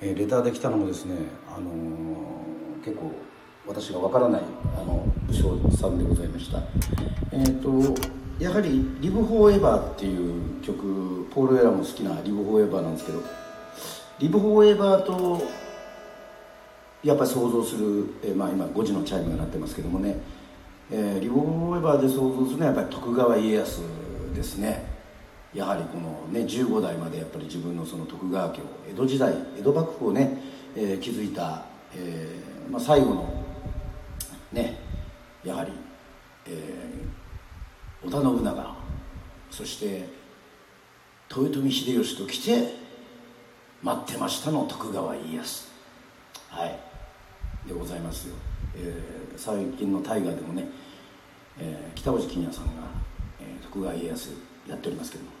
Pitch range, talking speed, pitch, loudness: 85-130 Hz, 295 characters per minute, 100 Hz, -26 LUFS